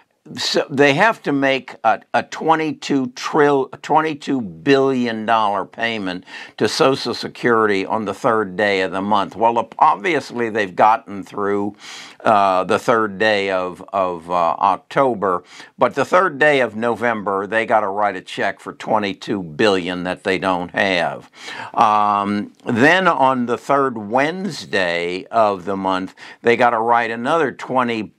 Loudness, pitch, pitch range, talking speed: -18 LUFS, 115 Hz, 100-135 Hz, 145 wpm